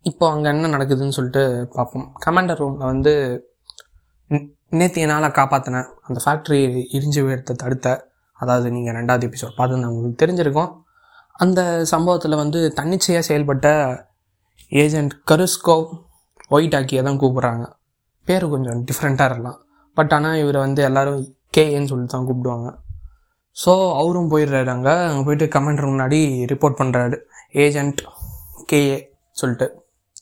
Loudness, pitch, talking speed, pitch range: -19 LUFS, 140 Hz, 120 wpm, 125-155 Hz